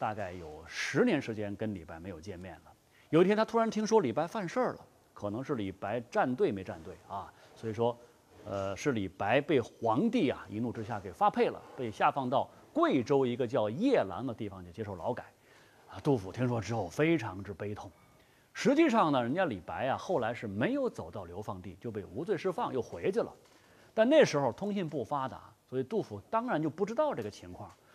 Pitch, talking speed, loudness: 120 Hz, 305 characters per minute, -32 LUFS